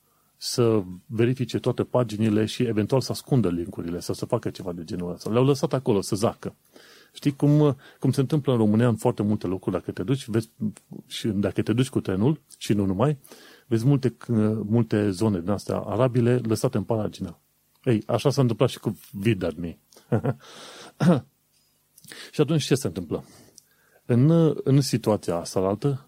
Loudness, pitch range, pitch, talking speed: -25 LUFS, 105-130 Hz, 115 Hz, 165 wpm